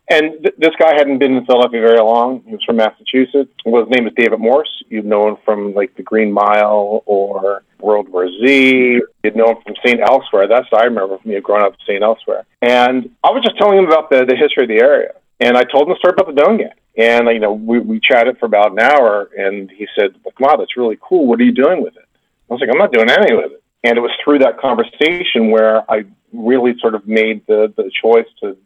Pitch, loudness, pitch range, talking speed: 120 Hz, -13 LUFS, 110-150 Hz, 255 wpm